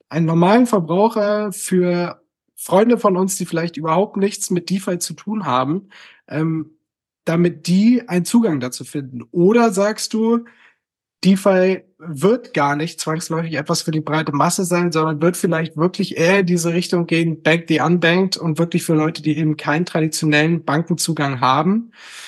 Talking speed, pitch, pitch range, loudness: 160 wpm, 170 Hz, 155-195 Hz, -18 LUFS